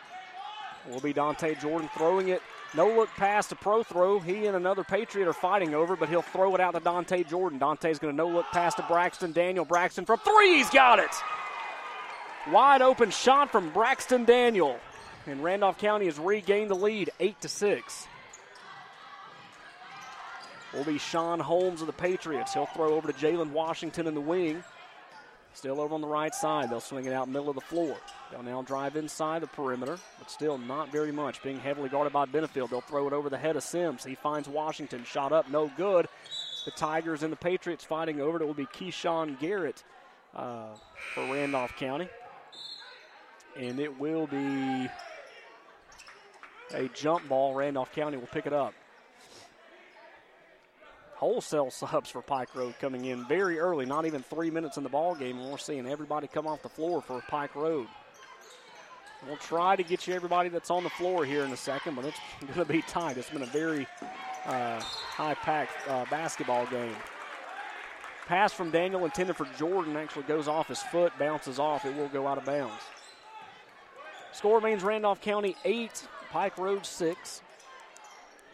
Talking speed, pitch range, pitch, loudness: 175 wpm, 145-180 Hz, 160 Hz, -29 LUFS